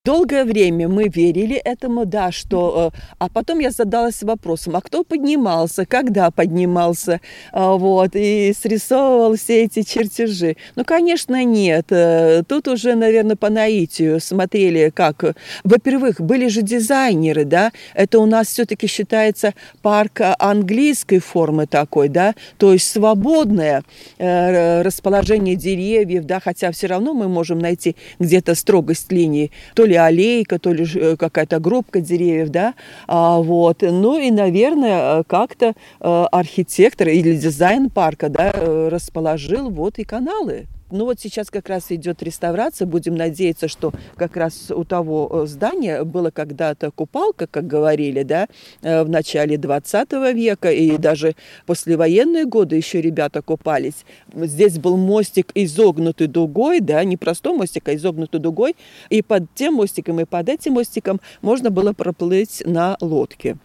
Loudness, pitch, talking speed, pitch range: -17 LUFS, 185 Hz, 140 wpm, 165-220 Hz